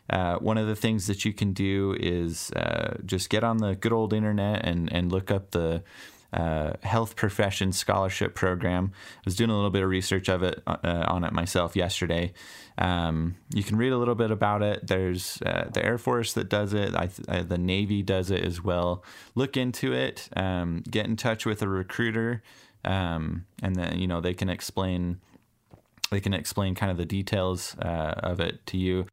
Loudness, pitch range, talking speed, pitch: -28 LUFS, 90-110 Hz, 200 wpm, 95 Hz